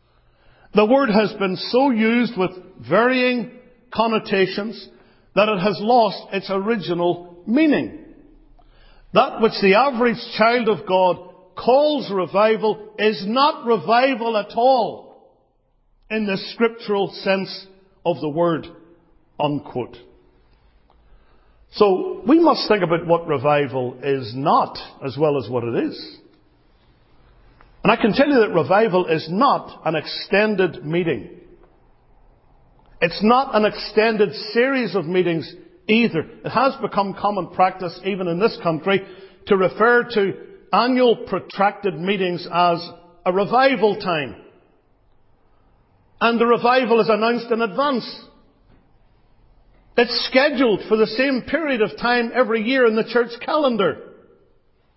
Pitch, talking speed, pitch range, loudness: 210 Hz, 125 wpm, 175-235 Hz, -19 LUFS